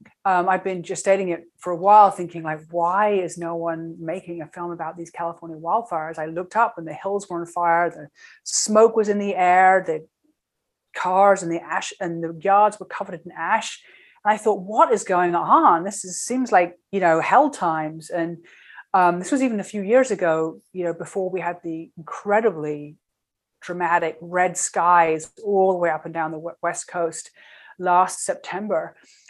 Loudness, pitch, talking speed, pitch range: -21 LUFS, 175 Hz, 195 wpm, 165-195 Hz